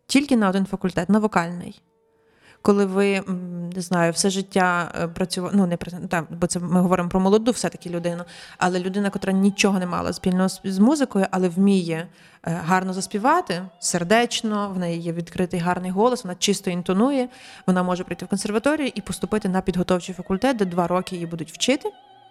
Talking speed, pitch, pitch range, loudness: 170 wpm, 185 Hz, 180-205 Hz, -22 LUFS